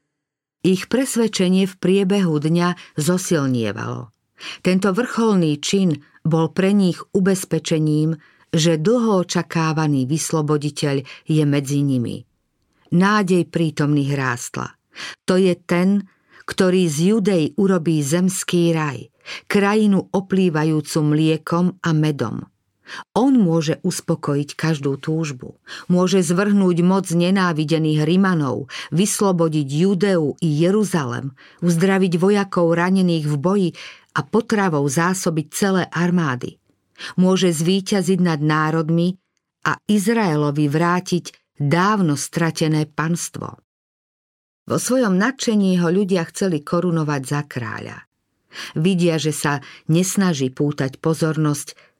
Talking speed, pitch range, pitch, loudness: 100 wpm, 150-190 Hz, 170 Hz, -19 LUFS